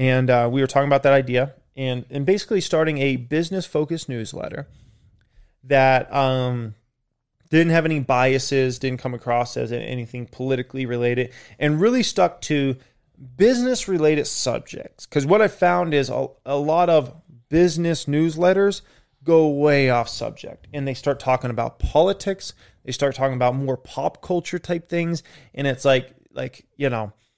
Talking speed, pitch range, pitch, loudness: 155 wpm, 125-160 Hz, 135 Hz, -21 LUFS